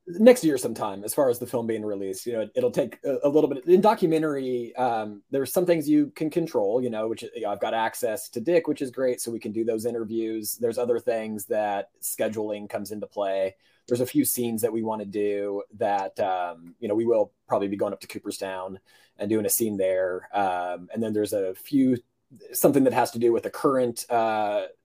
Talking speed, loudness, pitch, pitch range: 230 wpm, -26 LUFS, 115 Hz, 105-145 Hz